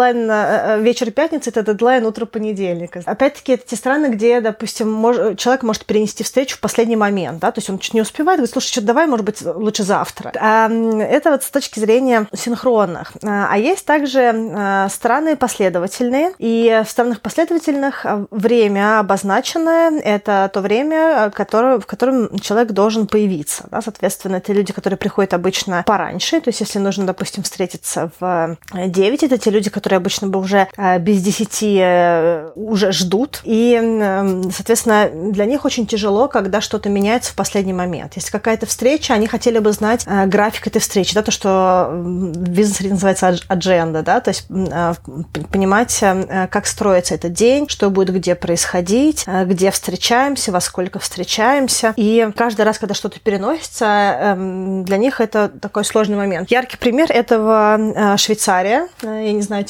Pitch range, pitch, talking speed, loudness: 195-235 Hz, 215 Hz, 165 wpm, -16 LUFS